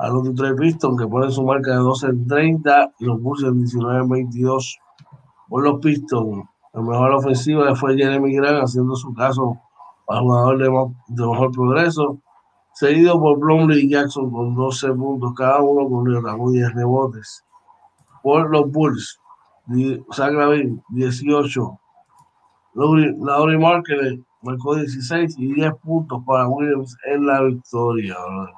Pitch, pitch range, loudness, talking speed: 135 Hz, 125-145 Hz, -18 LUFS, 145 wpm